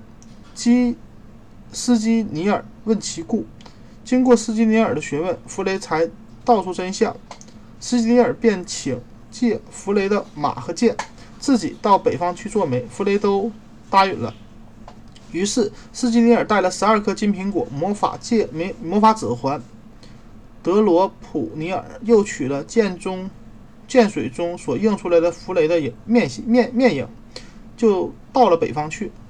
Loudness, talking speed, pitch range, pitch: -20 LUFS, 215 characters per minute, 170-230 Hz, 205 Hz